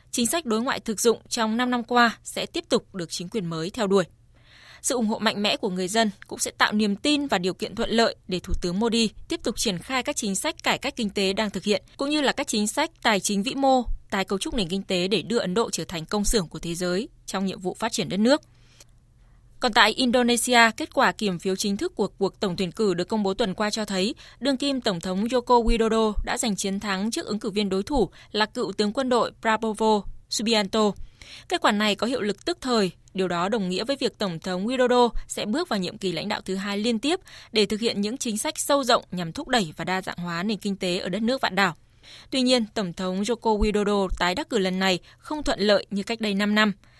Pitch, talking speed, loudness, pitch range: 215 Hz, 260 wpm, -24 LUFS, 190-235 Hz